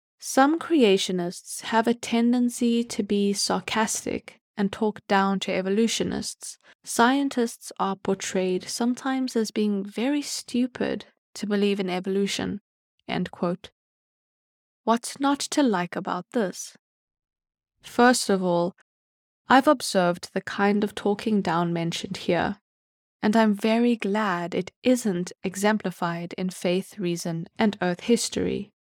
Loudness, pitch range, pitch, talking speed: -25 LUFS, 185-235 Hz, 205 Hz, 120 wpm